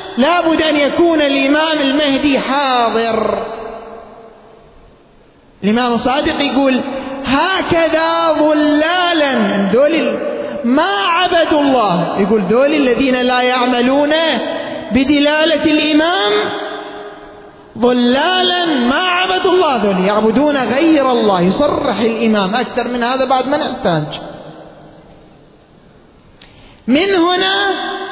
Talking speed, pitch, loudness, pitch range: 85 wpm, 280 Hz, -13 LUFS, 240-315 Hz